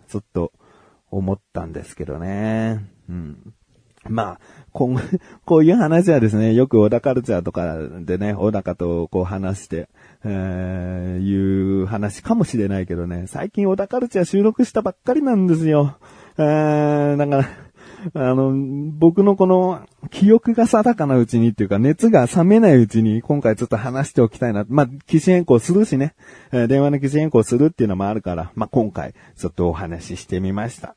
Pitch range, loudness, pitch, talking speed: 100-160 Hz, -18 LUFS, 120 Hz, 350 characters per minute